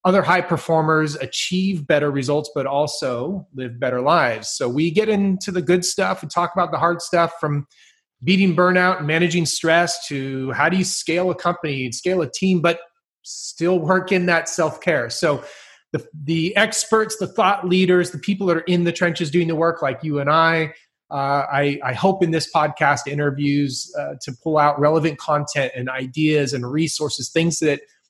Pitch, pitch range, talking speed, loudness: 165 Hz, 145-180 Hz, 190 wpm, -20 LUFS